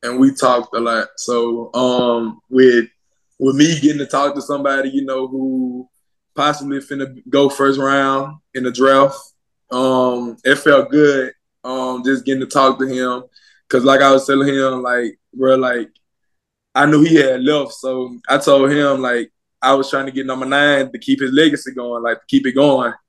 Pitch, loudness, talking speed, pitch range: 135 Hz, -15 LUFS, 190 wpm, 125-140 Hz